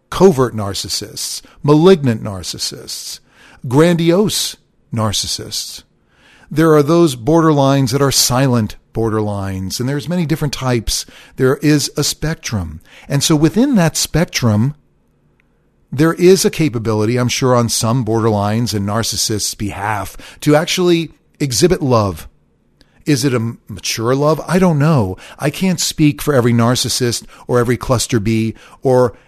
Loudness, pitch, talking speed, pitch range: -15 LUFS, 125 Hz, 130 wpm, 110-155 Hz